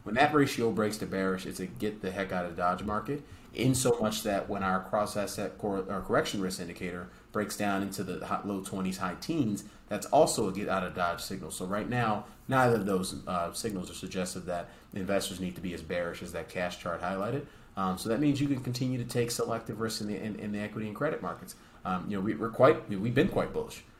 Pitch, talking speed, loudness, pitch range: 100 Hz, 240 wpm, -32 LUFS, 95-115 Hz